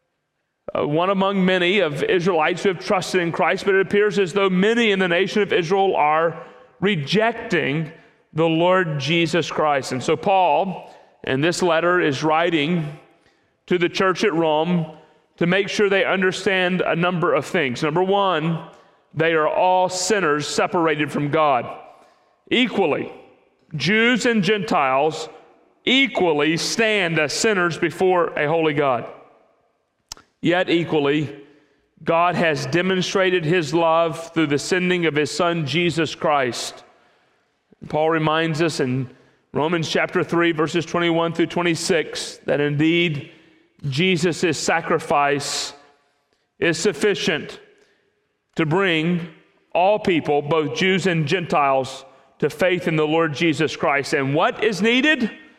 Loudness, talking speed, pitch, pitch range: -20 LUFS, 130 wpm, 170 Hz, 155-195 Hz